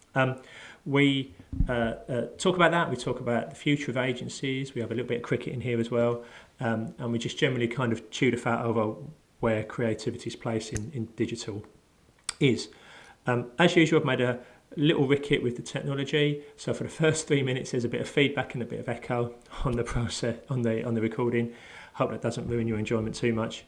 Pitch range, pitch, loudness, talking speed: 115-140 Hz, 120 Hz, -28 LUFS, 220 wpm